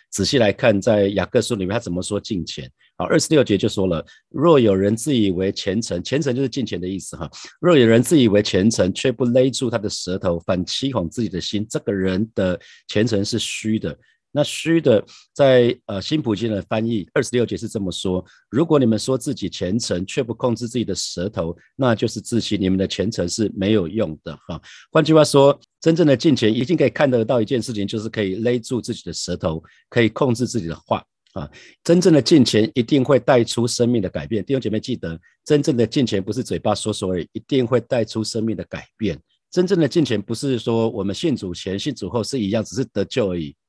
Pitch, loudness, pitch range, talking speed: 110 Hz, -20 LUFS, 95-125 Hz, 325 characters per minute